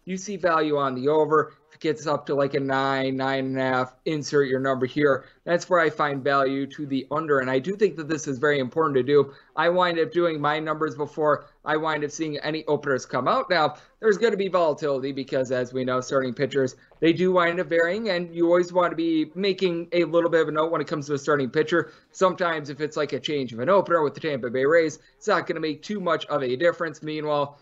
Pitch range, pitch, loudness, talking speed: 140-170 Hz, 155 Hz, -24 LUFS, 255 wpm